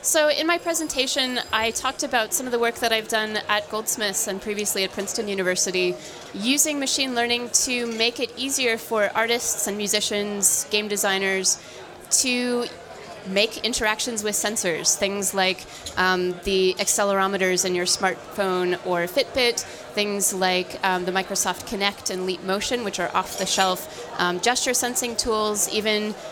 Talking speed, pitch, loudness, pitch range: 150 wpm, 210 Hz, -22 LUFS, 190-240 Hz